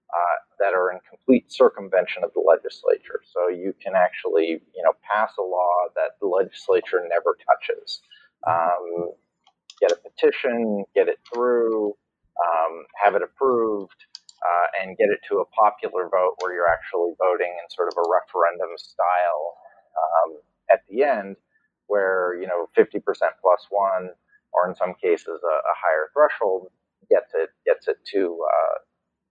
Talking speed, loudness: 155 wpm, -23 LUFS